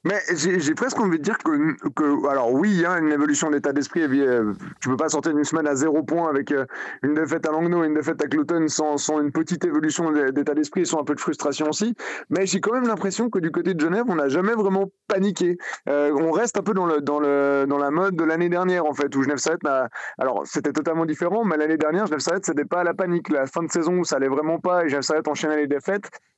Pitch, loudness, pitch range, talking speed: 160 Hz, -22 LUFS, 145-180 Hz, 255 wpm